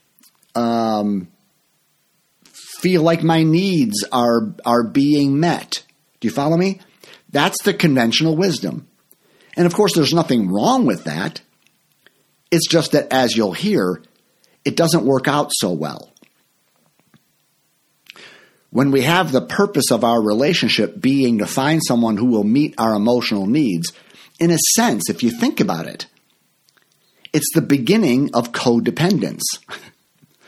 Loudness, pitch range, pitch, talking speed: -17 LUFS, 120-170 Hz, 140 Hz, 135 wpm